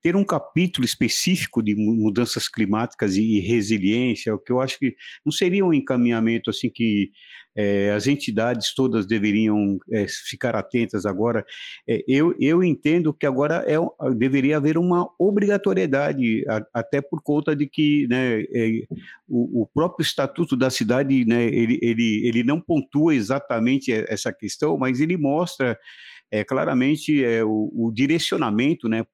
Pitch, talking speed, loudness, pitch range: 125 Hz, 150 wpm, -22 LUFS, 110-150 Hz